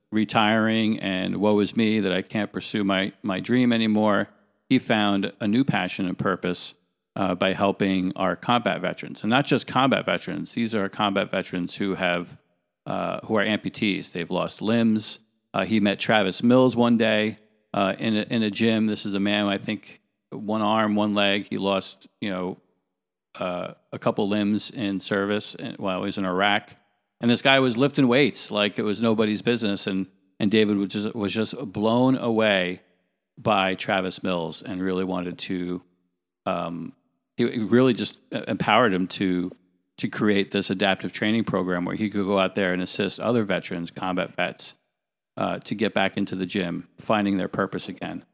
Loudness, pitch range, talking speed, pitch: -24 LUFS, 95-110 Hz, 180 wpm, 100 Hz